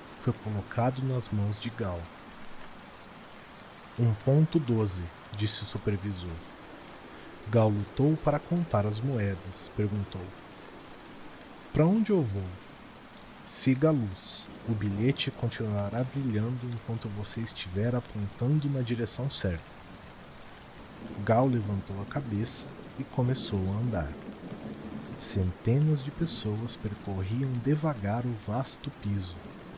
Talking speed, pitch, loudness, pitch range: 105 wpm, 115 Hz, -31 LUFS, 100-130 Hz